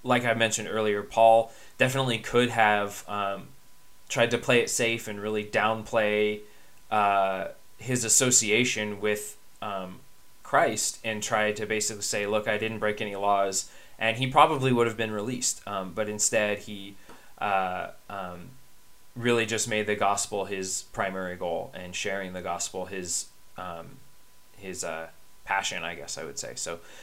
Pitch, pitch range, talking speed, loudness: 105 Hz, 100-115 Hz, 155 wpm, -26 LUFS